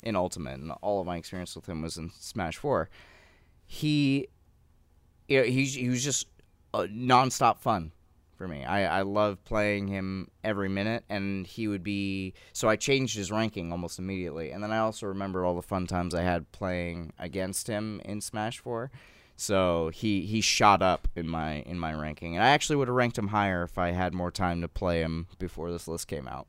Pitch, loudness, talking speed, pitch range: 95 Hz, -29 LUFS, 205 wpm, 85-105 Hz